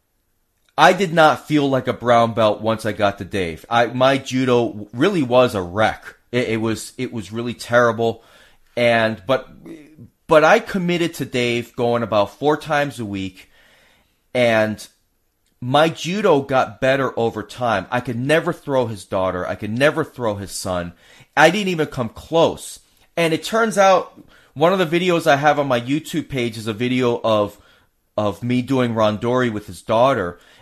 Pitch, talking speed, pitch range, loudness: 120 Hz, 175 wpm, 110-145 Hz, -19 LUFS